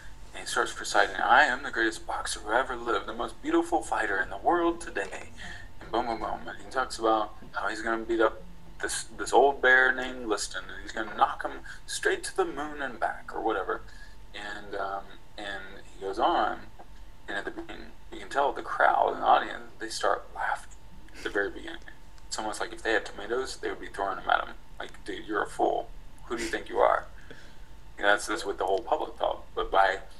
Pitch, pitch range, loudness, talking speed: 110 Hz, 100-130 Hz, -29 LUFS, 225 wpm